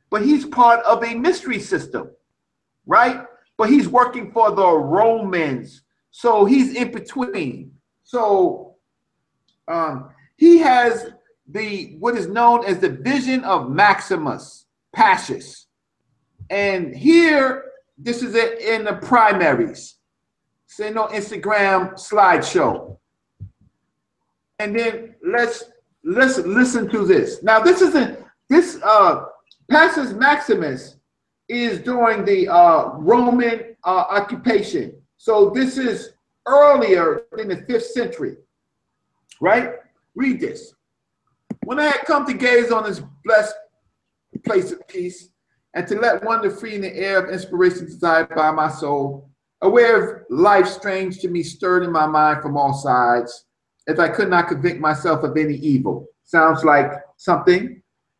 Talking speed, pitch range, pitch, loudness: 130 wpm, 180-265 Hz, 225 Hz, -17 LUFS